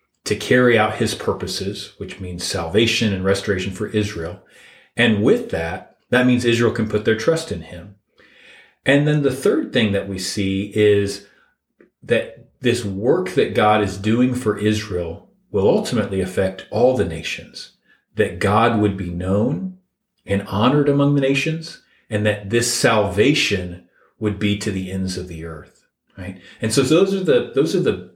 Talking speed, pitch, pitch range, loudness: 170 wpm, 105 Hz, 95-120 Hz, -19 LUFS